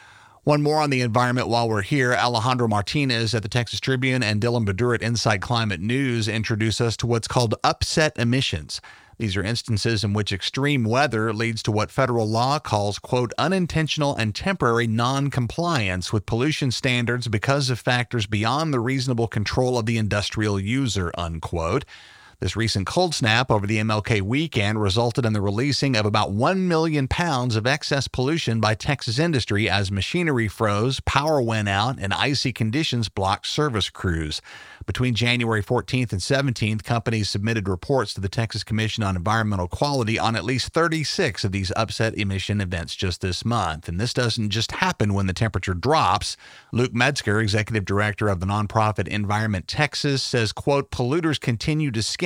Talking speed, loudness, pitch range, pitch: 170 wpm, -22 LUFS, 105-130 Hz, 115 Hz